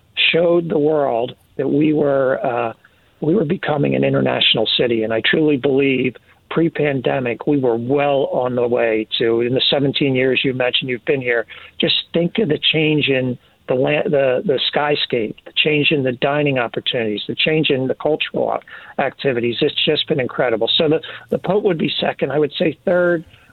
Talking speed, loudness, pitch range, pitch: 185 wpm, -17 LUFS, 120-150 Hz, 135 Hz